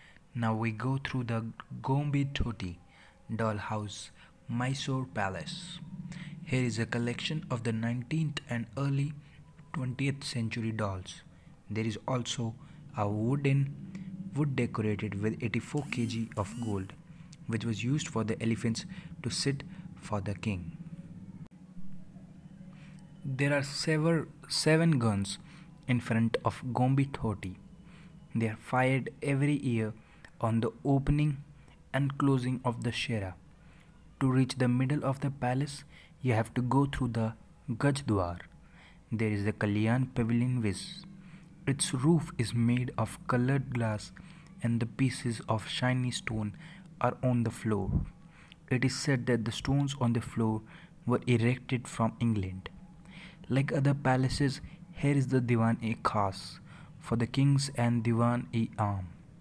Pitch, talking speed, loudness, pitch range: 130 Hz, 135 wpm, -32 LUFS, 115-150 Hz